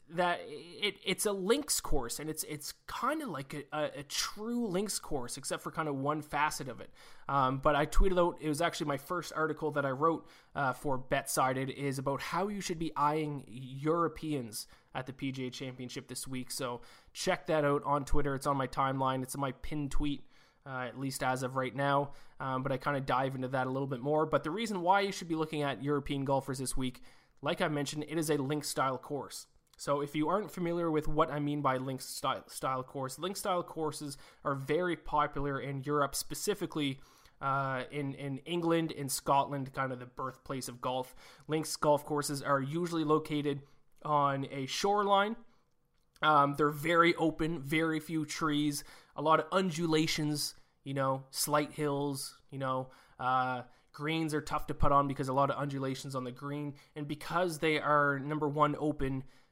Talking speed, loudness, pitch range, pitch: 200 wpm, -33 LUFS, 135-155 Hz, 145 Hz